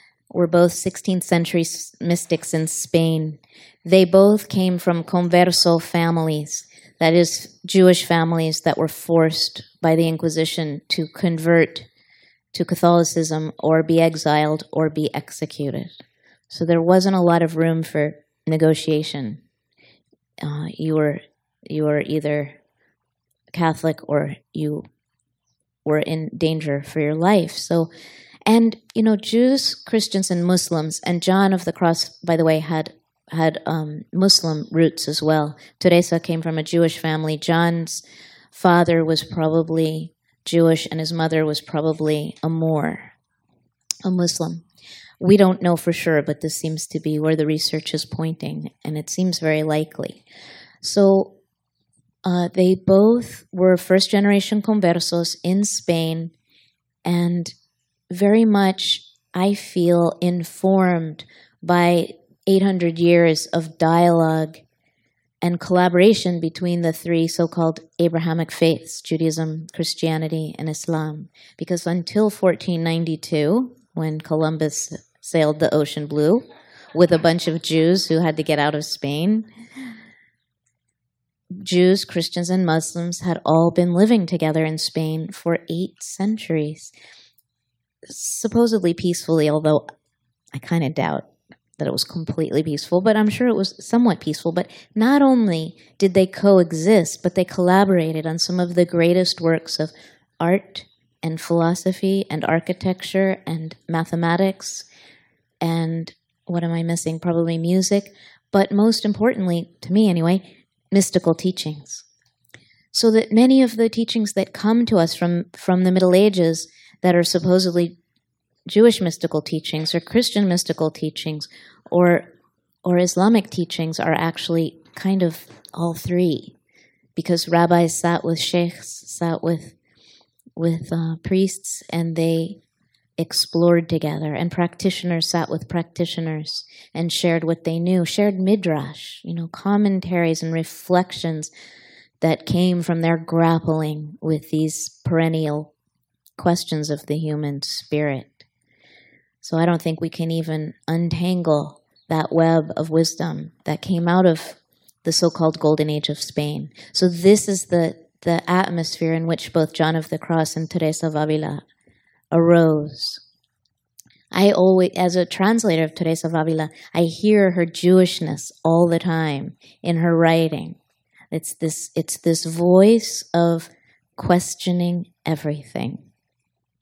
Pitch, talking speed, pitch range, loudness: 165 Hz, 135 wpm, 160-180 Hz, -20 LUFS